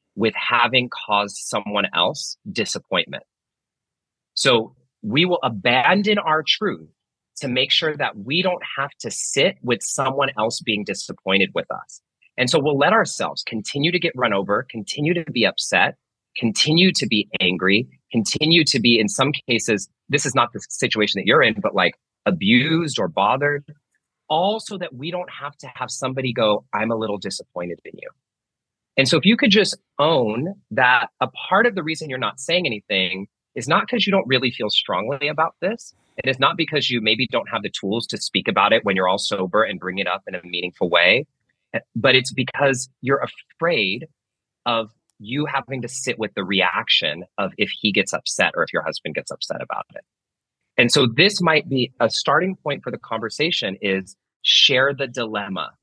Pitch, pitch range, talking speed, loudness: 130 Hz, 110-160 Hz, 190 wpm, -20 LUFS